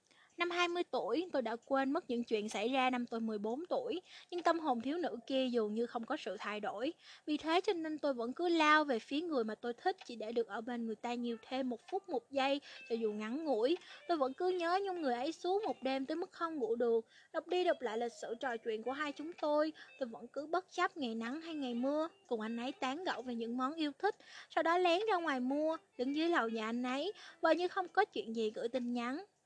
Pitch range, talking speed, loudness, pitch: 240-335 Hz, 260 wpm, -37 LUFS, 270 Hz